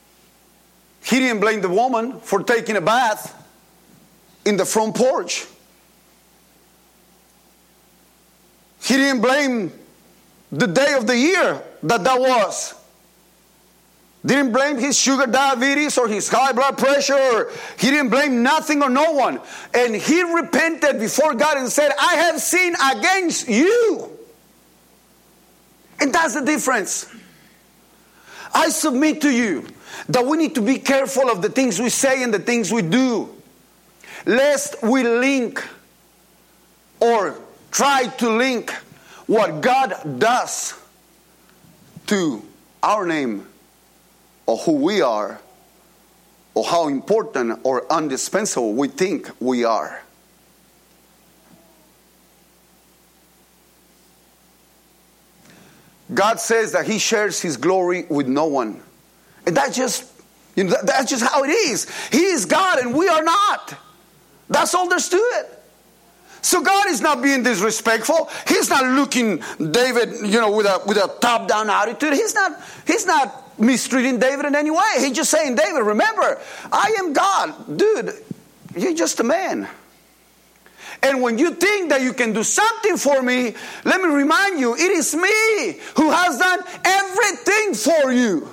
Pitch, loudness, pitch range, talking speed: 270 Hz, -18 LUFS, 235-320 Hz, 135 wpm